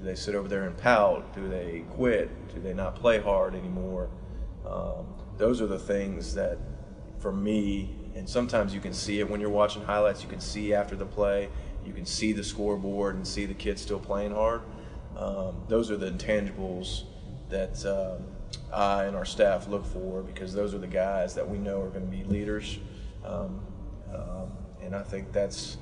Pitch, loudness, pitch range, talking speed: 100 Hz, -30 LUFS, 95-105 Hz, 195 wpm